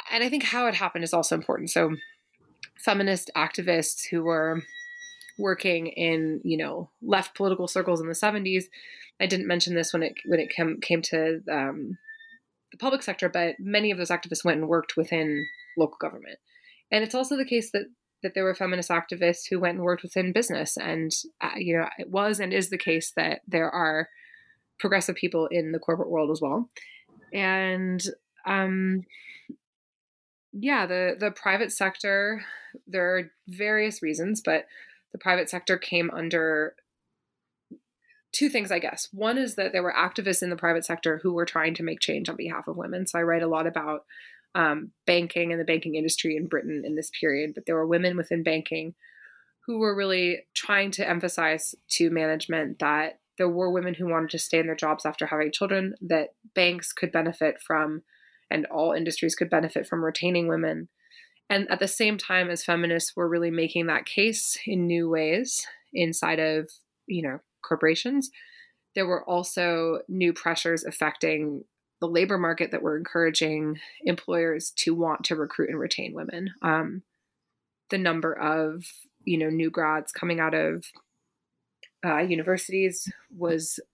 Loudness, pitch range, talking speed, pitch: -26 LUFS, 160-195 Hz, 170 wpm, 175 Hz